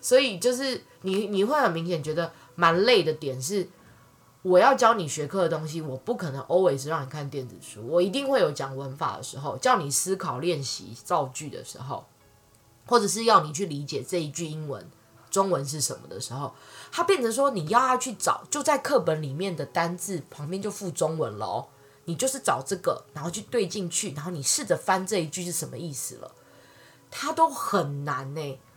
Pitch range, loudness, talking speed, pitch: 140-200 Hz, -26 LUFS, 300 characters per minute, 170 Hz